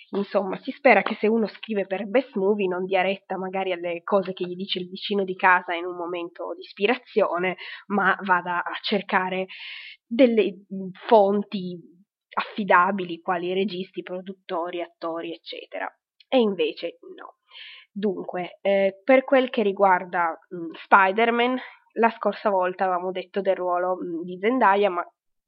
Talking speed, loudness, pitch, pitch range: 145 wpm, -24 LUFS, 190 Hz, 180-210 Hz